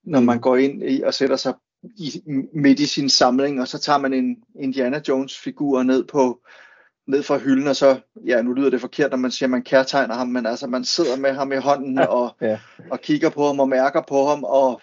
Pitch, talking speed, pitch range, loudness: 135 Hz, 230 wpm, 130-145 Hz, -20 LUFS